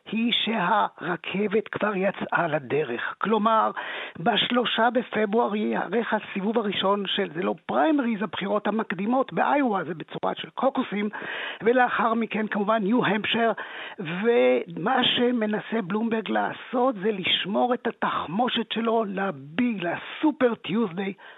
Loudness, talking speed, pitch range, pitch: -25 LUFS, 110 wpm, 200-240 Hz, 220 Hz